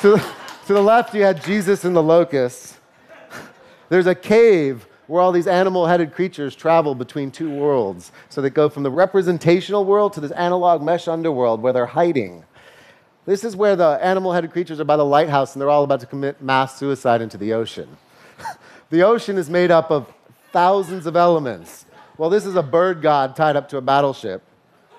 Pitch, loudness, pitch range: 165 Hz, -18 LUFS, 140-185 Hz